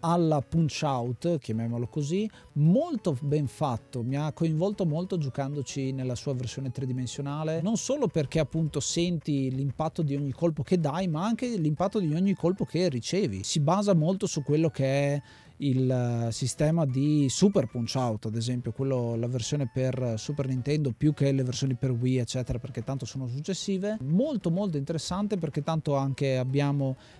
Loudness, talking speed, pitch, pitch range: -28 LUFS, 165 wpm, 145 Hz, 130-170 Hz